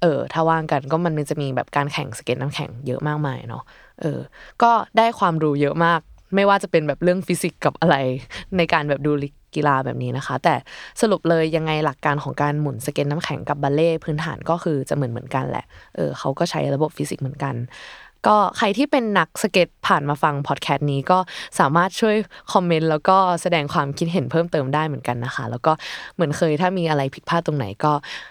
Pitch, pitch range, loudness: 155 Hz, 140-170 Hz, -21 LUFS